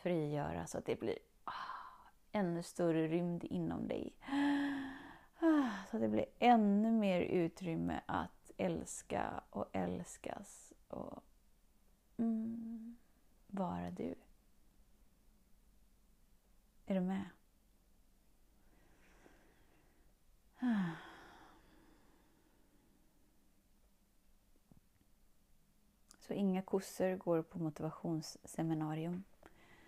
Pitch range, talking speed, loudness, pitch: 165-230 Hz, 70 wpm, -39 LUFS, 190 Hz